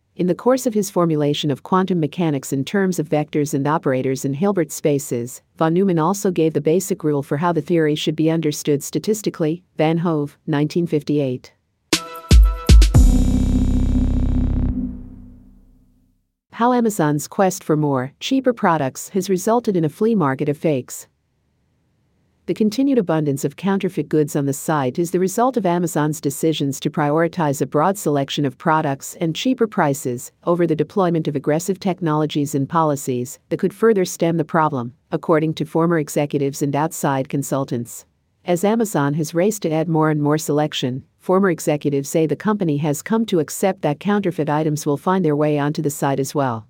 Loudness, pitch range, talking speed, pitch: -19 LUFS, 145-175 Hz, 165 wpm, 155 Hz